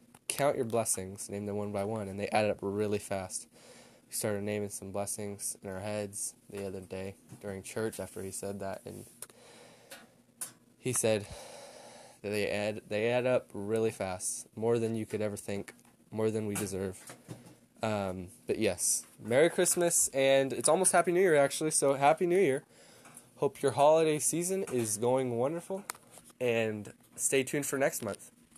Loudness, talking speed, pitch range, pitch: -31 LUFS, 170 wpm, 100-135 Hz, 110 Hz